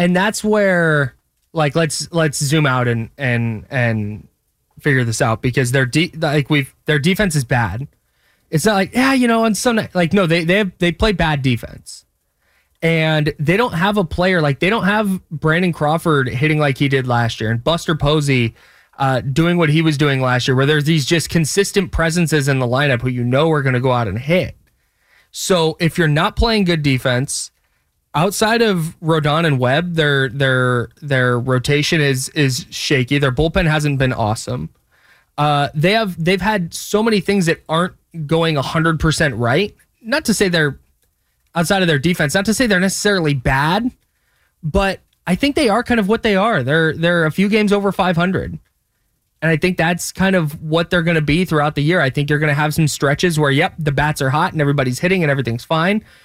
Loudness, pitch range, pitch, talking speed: -16 LUFS, 140-180 Hz, 160 Hz, 205 wpm